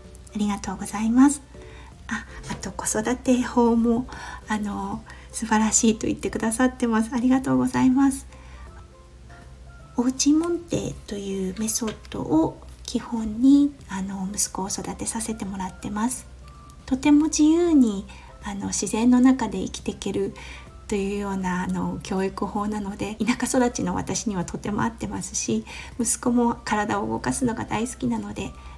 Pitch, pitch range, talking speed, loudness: 210 Hz, 180-240 Hz, 300 characters per minute, -24 LUFS